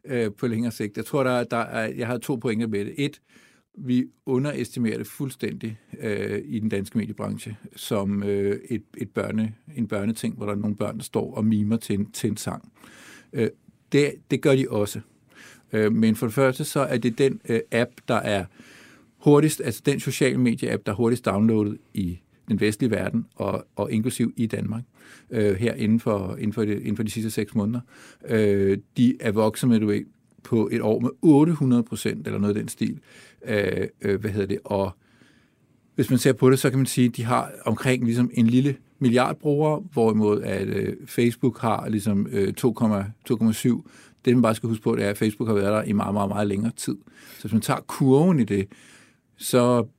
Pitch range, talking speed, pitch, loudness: 105-125 Hz, 205 wpm, 115 Hz, -24 LUFS